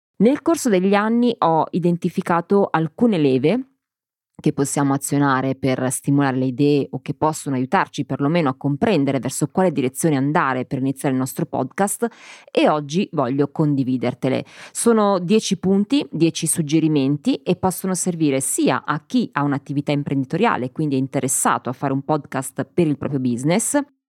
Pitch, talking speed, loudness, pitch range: 150 Hz, 150 wpm, -20 LUFS, 135-185 Hz